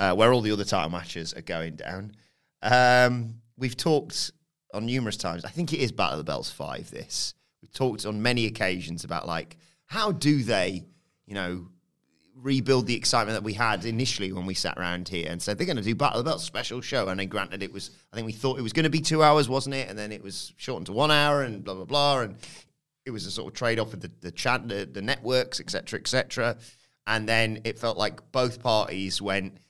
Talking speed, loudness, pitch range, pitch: 240 wpm, -27 LUFS, 100-130 Hz, 115 Hz